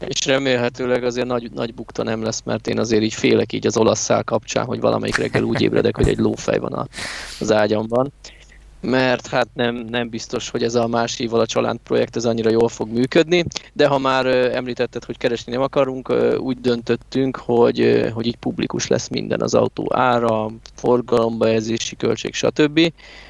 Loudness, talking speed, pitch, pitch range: -19 LUFS, 180 wpm, 120 Hz, 115-130 Hz